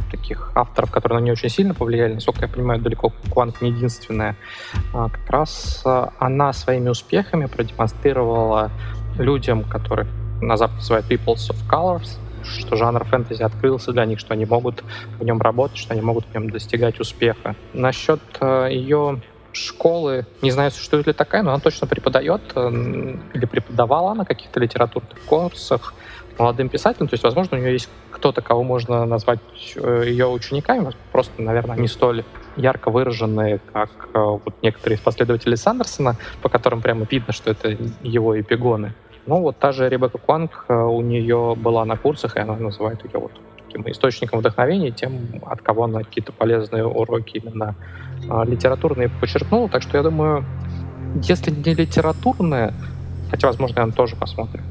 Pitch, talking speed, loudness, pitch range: 120 Hz, 155 wpm, -20 LUFS, 110-130 Hz